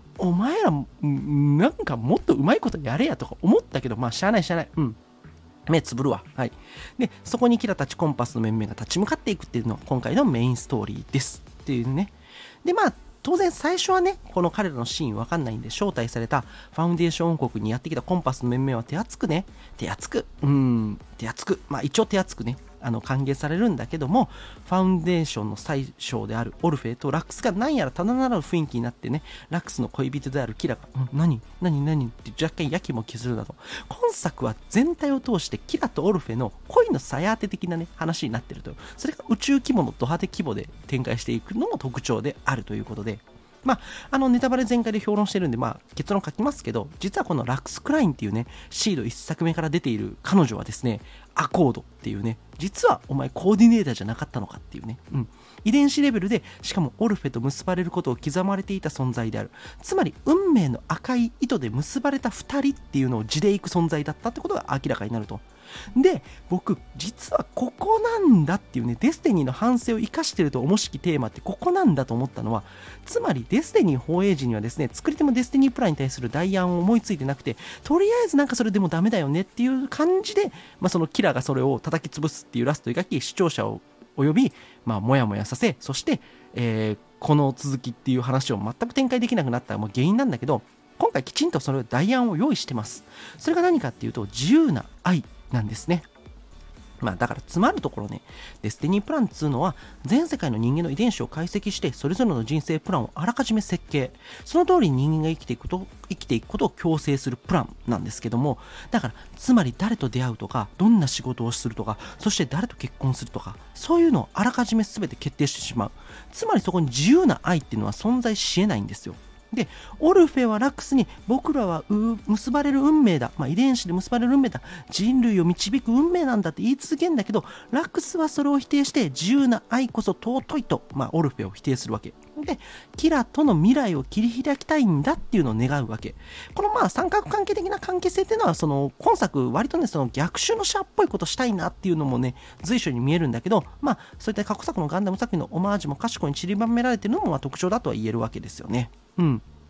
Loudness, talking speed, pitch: -24 LUFS, 450 characters per minute, 170 Hz